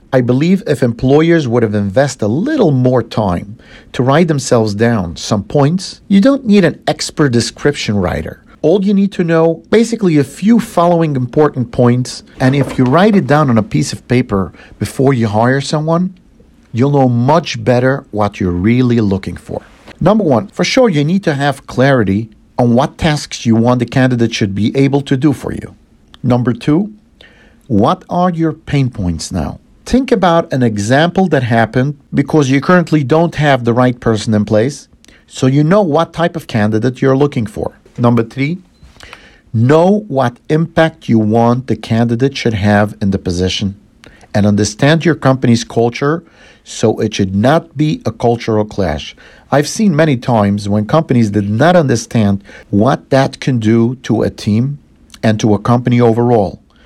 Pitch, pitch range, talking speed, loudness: 125 Hz, 110-155 Hz, 175 wpm, -13 LUFS